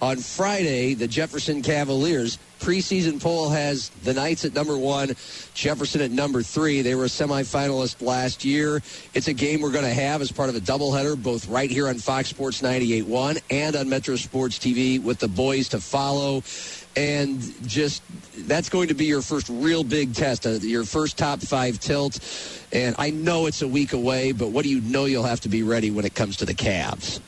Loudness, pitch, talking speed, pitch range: -24 LUFS, 135 Hz, 200 wpm, 125-150 Hz